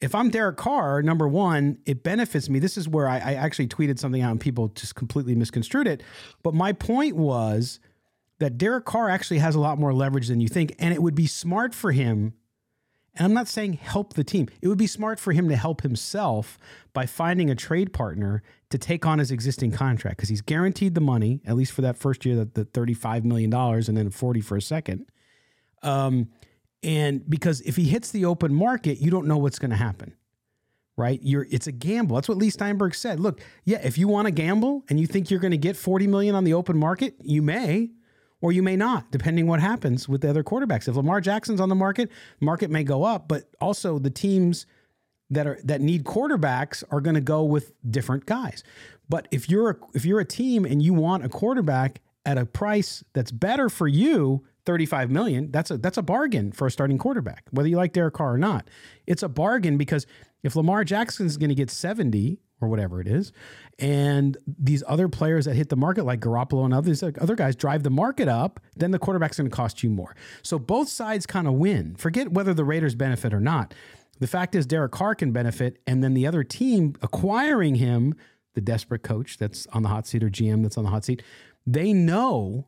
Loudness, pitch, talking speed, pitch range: -24 LUFS, 150 Hz, 220 wpm, 125-180 Hz